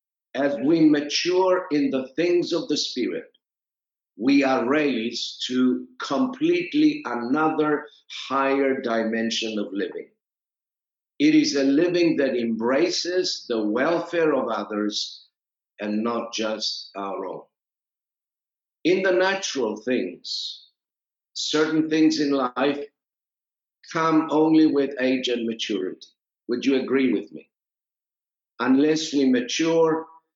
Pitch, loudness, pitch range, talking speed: 140 Hz, -23 LUFS, 120-160 Hz, 110 wpm